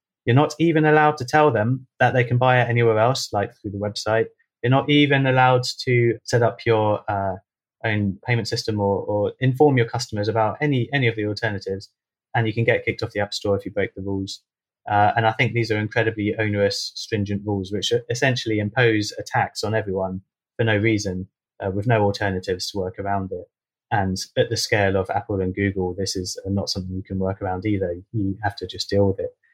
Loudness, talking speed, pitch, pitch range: -22 LUFS, 215 wpm, 110 Hz, 100-120 Hz